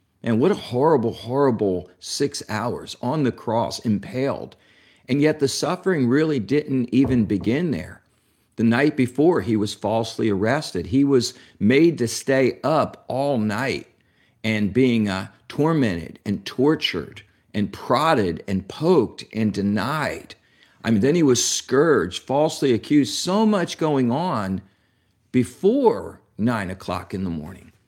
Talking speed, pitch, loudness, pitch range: 140 wpm, 115 Hz, -22 LUFS, 105-135 Hz